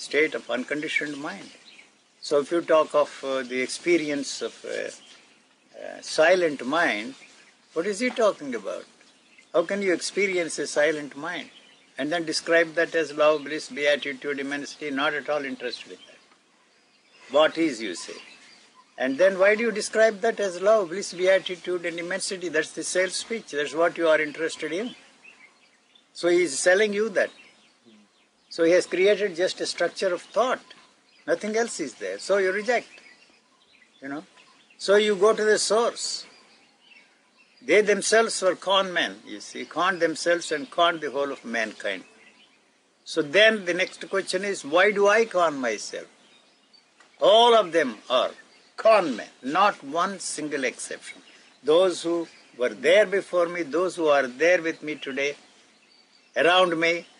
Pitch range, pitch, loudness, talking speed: 155-220 Hz, 180 Hz, -24 LUFS, 160 wpm